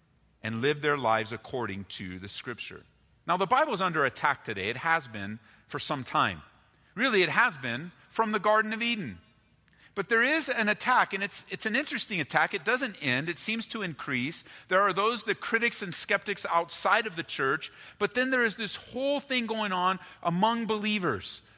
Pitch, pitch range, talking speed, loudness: 195 Hz, 140-225 Hz, 195 wpm, -28 LUFS